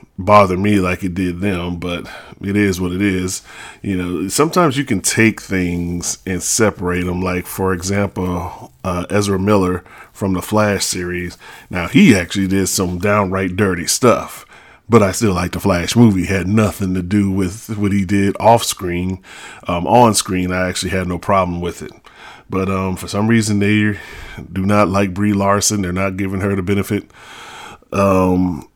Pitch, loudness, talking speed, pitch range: 95 Hz, -16 LUFS, 180 wpm, 90-100 Hz